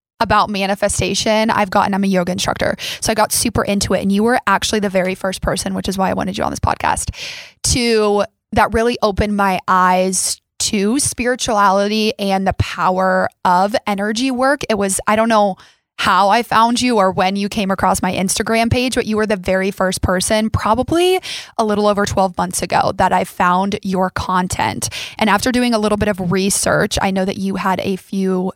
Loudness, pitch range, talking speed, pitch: -16 LUFS, 190-220 Hz, 200 wpm, 200 Hz